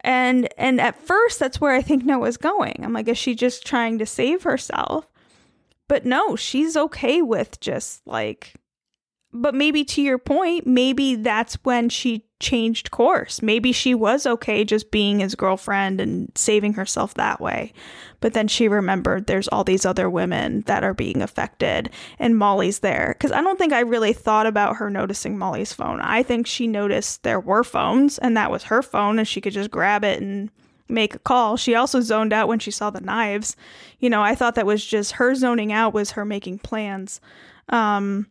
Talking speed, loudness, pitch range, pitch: 195 wpm, -21 LUFS, 210-255 Hz, 230 Hz